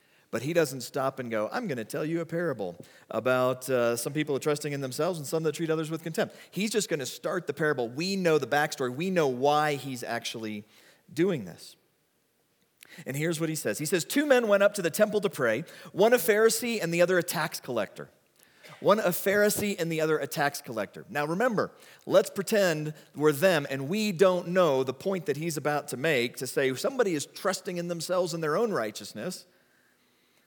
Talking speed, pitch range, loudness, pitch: 210 wpm, 140-190 Hz, -28 LUFS, 160 Hz